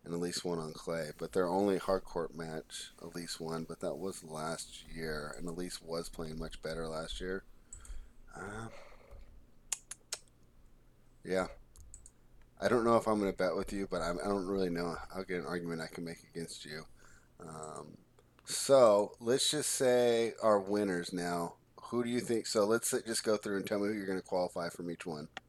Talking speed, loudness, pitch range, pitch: 185 wpm, -35 LUFS, 80-100 Hz, 85 Hz